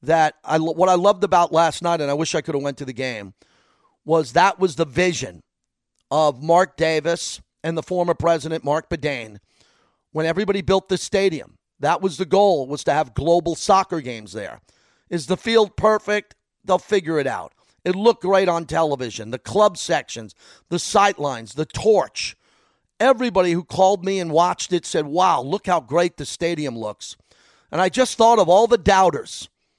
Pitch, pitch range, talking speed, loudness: 170 Hz, 150-190 Hz, 185 wpm, -20 LUFS